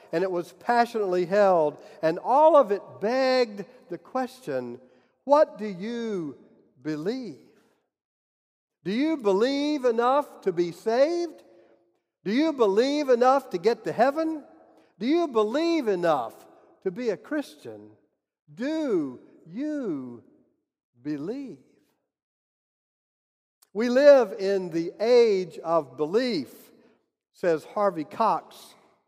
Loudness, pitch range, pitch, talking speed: -25 LUFS, 175-285 Hz, 230 Hz, 105 wpm